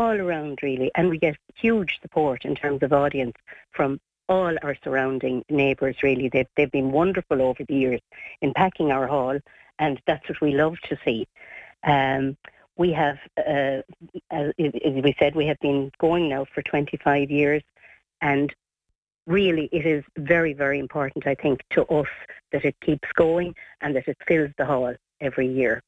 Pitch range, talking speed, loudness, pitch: 135-160 Hz, 170 wpm, -24 LUFS, 145 Hz